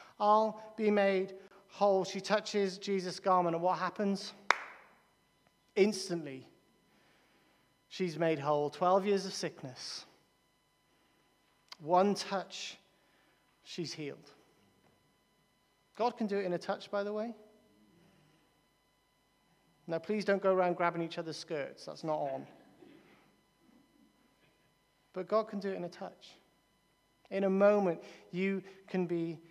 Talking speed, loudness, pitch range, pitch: 120 wpm, -34 LUFS, 170-200 Hz, 190 Hz